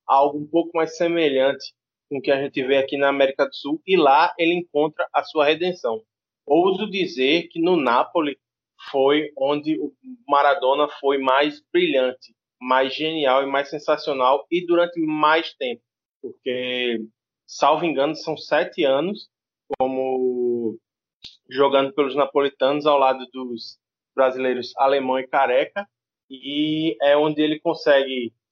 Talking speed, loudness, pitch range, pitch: 140 wpm, -21 LUFS, 130-160 Hz, 140 Hz